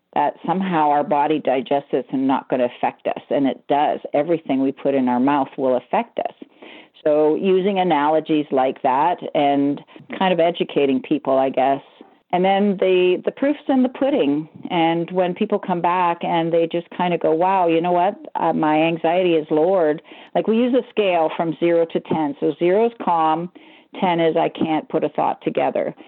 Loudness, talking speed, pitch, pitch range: -19 LUFS, 195 wpm, 170 Hz, 150-190 Hz